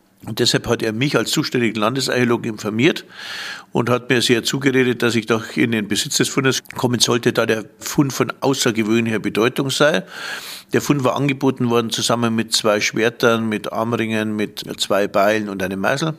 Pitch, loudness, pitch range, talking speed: 115 Hz, -18 LUFS, 110-130 Hz, 180 wpm